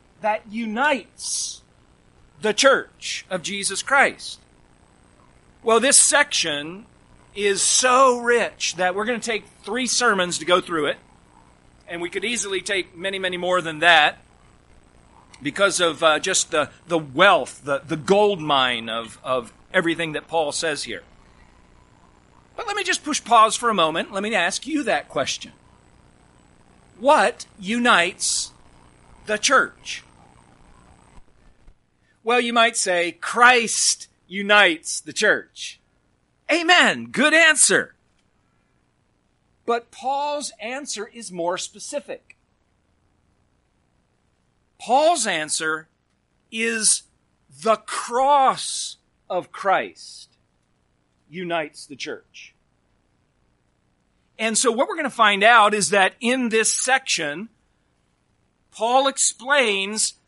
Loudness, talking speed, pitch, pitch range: -20 LUFS, 110 wpm, 205 Hz, 165-240 Hz